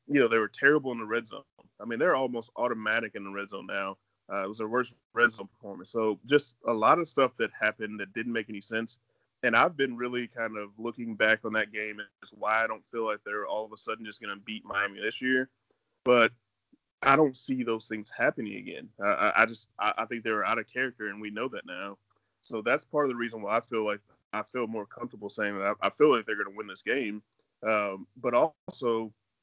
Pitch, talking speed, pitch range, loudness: 110 Hz, 245 wpm, 105-120 Hz, -29 LUFS